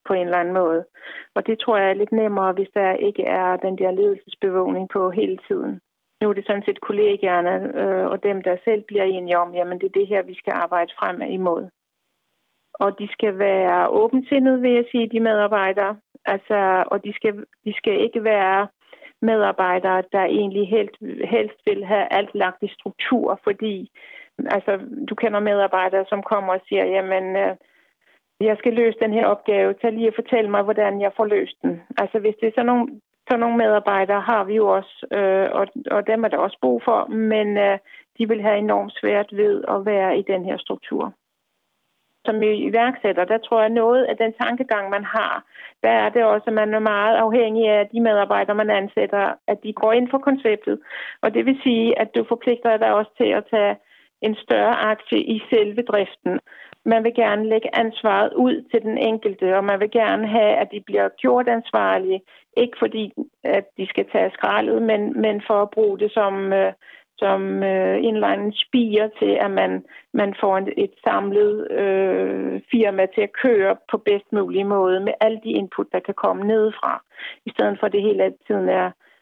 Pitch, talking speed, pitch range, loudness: 210 Hz, 195 wpm, 195-225 Hz, -20 LUFS